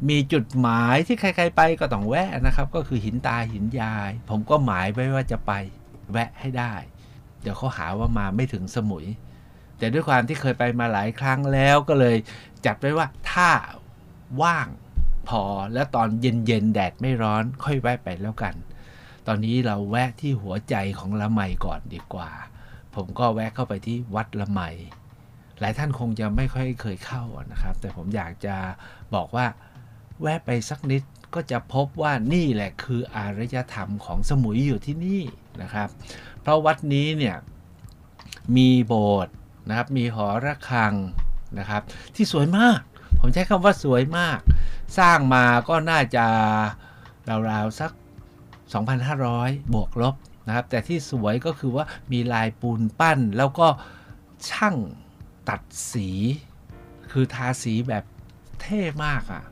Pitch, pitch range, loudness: 120 Hz, 105-130 Hz, -24 LUFS